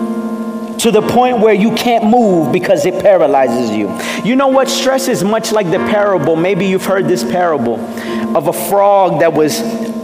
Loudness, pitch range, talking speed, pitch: -12 LUFS, 180-225 Hz, 180 wpm, 210 Hz